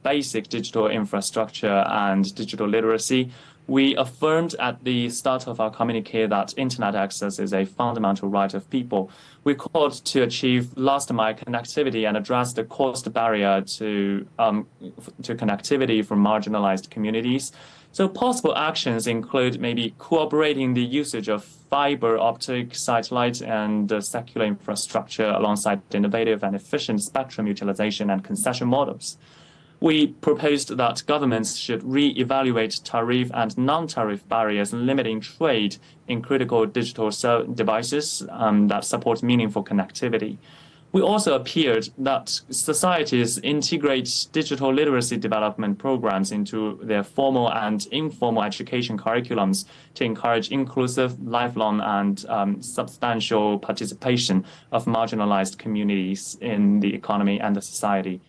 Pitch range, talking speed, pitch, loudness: 105-135 Hz, 125 wpm, 115 Hz, -23 LUFS